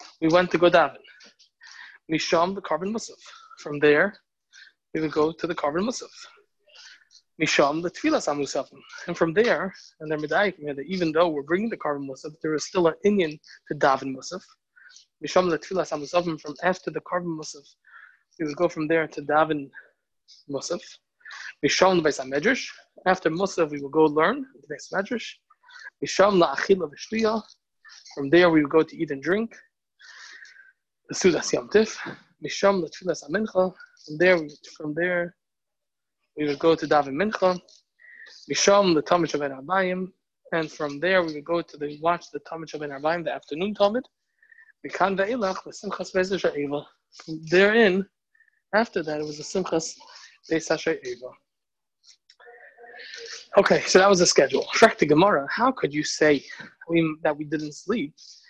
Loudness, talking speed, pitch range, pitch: -24 LUFS, 155 wpm, 155-200 Hz, 175 Hz